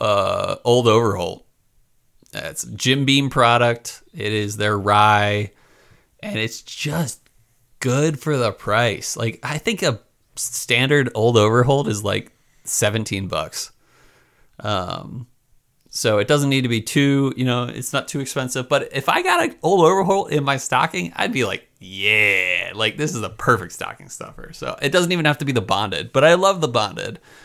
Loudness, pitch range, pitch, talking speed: -19 LUFS, 110-145 Hz, 125 Hz, 170 wpm